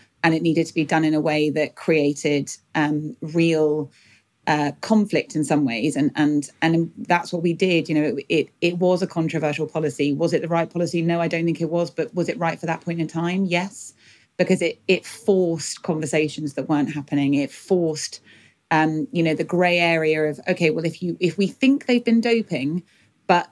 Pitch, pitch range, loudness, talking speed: 165 Hz, 150-175 Hz, -22 LUFS, 210 wpm